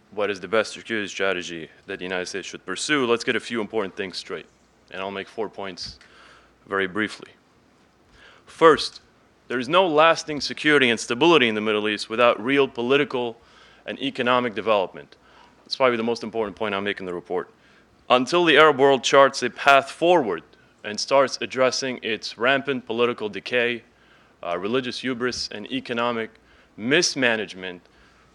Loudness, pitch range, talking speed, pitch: -22 LUFS, 105-135 Hz, 160 wpm, 120 Hz